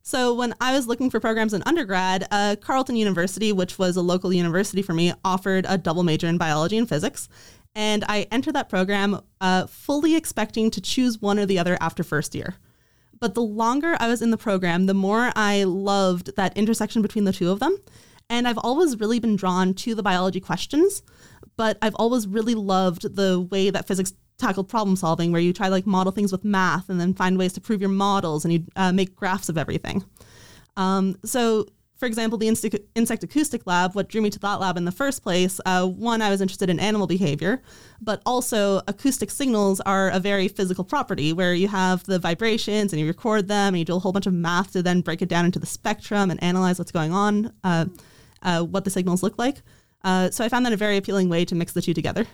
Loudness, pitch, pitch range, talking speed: -23 LUFS, 195 Hz, 185-220 Hz, 225 wpm